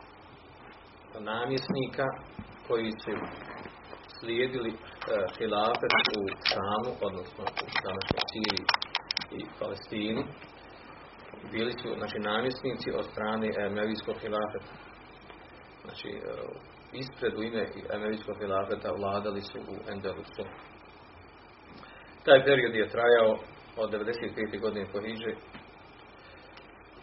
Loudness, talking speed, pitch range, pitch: -31 LUFS, 80 wpm, 105-115 Hz, 110 Hz